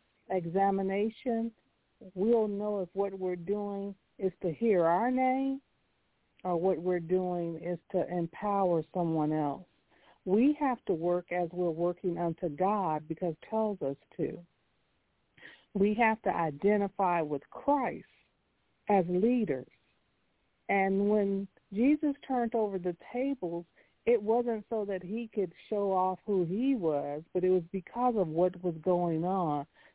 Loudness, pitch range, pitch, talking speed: -31 LUFS, 175-220 Hz, 190 Hz, 140 wpm